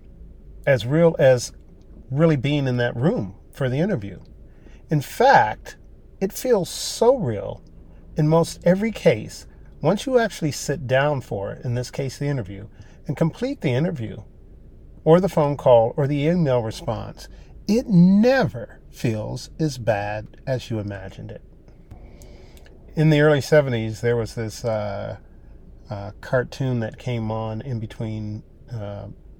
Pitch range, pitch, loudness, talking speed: 100-150 Hz, 120 Hz, -21 LUFS, 145 wpm